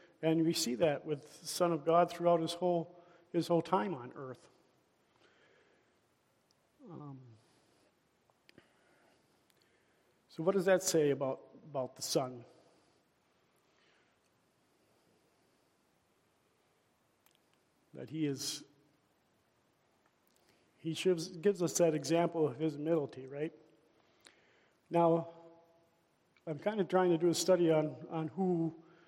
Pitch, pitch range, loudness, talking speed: 165 Hz, 155-170 Hz, -34 LUFS, 105 wpm